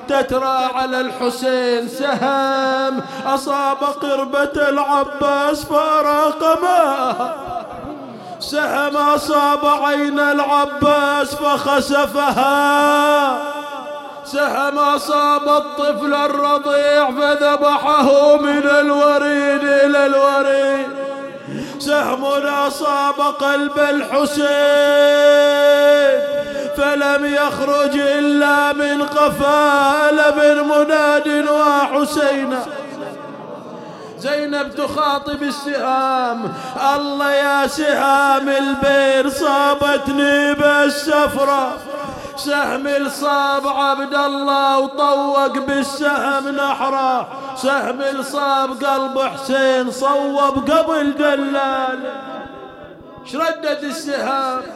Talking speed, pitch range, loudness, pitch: 65 wpm, 275-290 Hz, -16 LUFS, 285 Hz